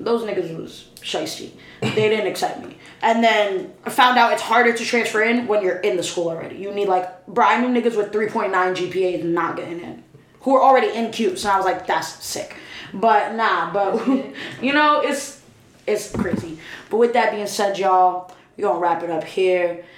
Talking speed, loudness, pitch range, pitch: 215 wpm, -20 LUFS, 180-230 Hz, 205 Hz